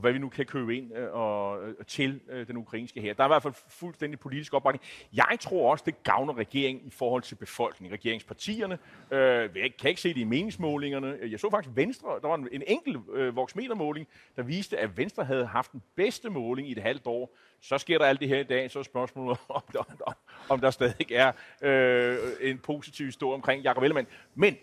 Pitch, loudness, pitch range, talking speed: 135 Hz, -29 LUFS, 125-145 Hz, 210 wpm